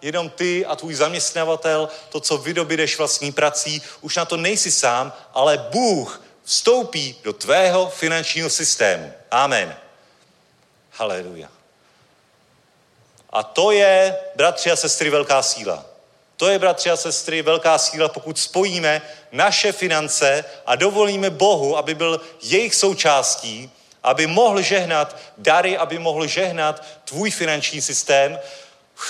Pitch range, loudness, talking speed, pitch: 150-185 Hz, -18 LUFS, 125 wpm, 160 Hz